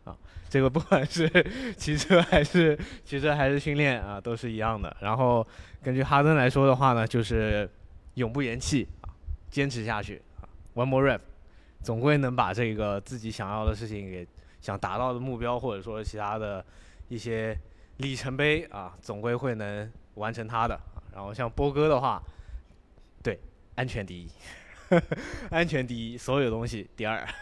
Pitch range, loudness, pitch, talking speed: 95-135 Hz, -28 LUFS, 115 Hz, 265 characters per minute